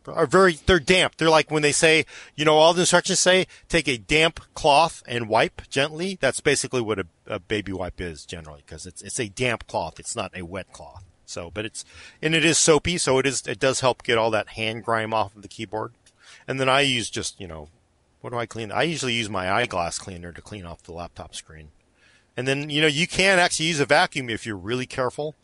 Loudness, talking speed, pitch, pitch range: -22 LUFS, 240 wpm, 120 Hz, 100-155 Hz